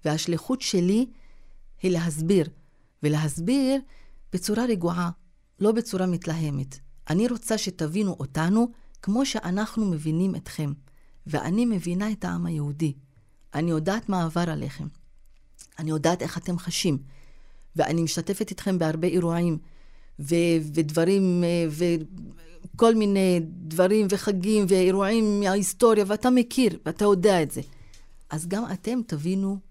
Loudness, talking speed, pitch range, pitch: -25 LUFS, 115 wpm, 160-205 Hz, 175 Hz